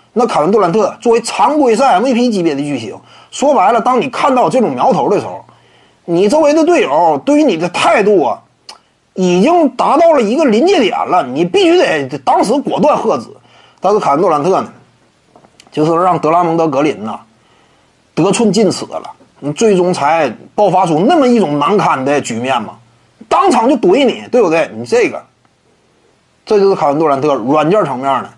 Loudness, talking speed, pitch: -11 LUFS, 280 characters per minute, 210 Hz